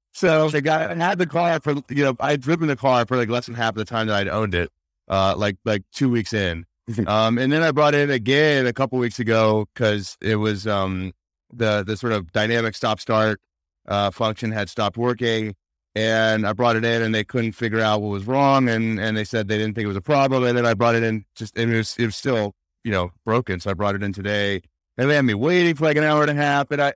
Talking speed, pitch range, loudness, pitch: 270 wpm, 105-130 Hz, -21 LUFS, 115 Hz